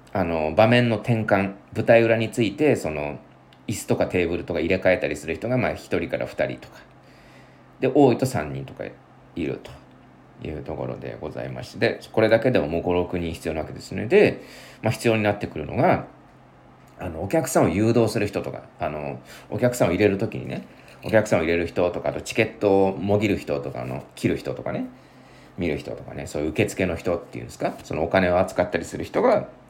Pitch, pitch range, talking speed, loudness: 100 Hz, 80-115 Hz, 380 characters per minute, -23 LUFS